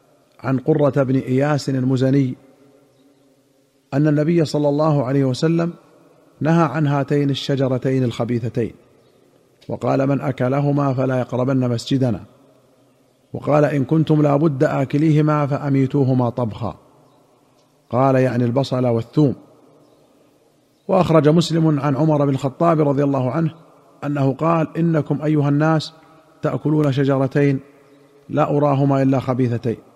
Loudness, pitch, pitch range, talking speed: -18 LUFS, 140 Hz, 130-150 Hz, 105 wpm